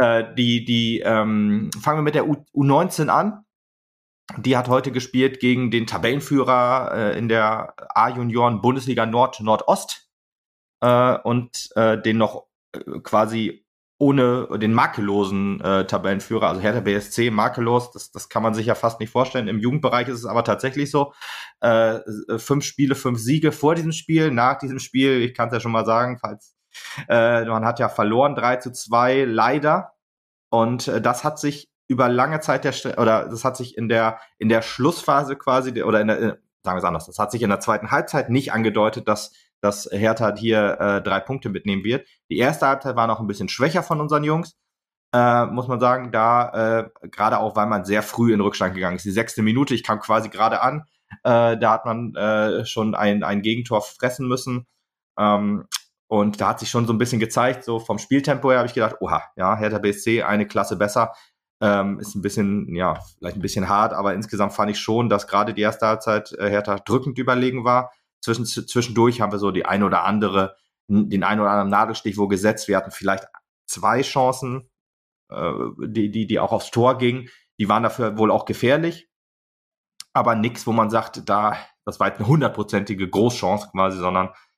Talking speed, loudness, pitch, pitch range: 190 wpm, -21 LUFS, 115 Hz, 105-125 Hz